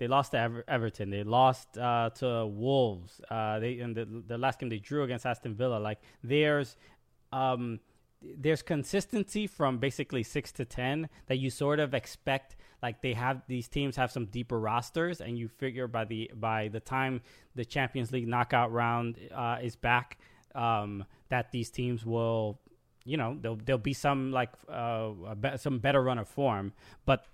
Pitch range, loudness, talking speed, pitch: 115-135 Hz, -32 LUFS, 180 wpm, 125 Hz